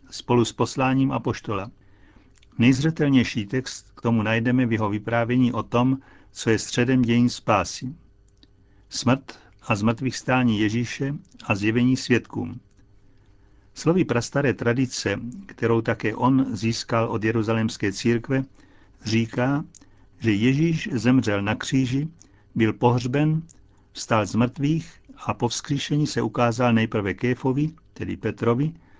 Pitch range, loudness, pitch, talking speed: 110-130 Hz, -23 LUFS, 120 Hz, 120 wpm